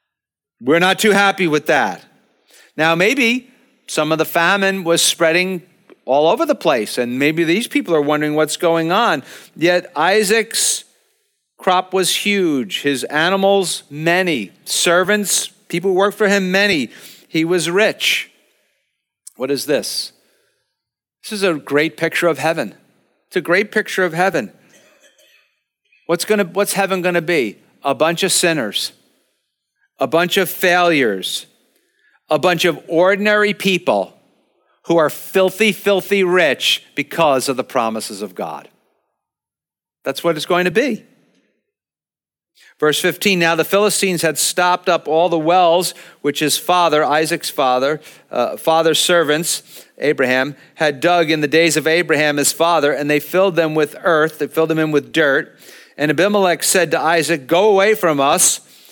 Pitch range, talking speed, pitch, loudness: 155-195 Hz, 150 wpm, 175 Hz, -16 LUFS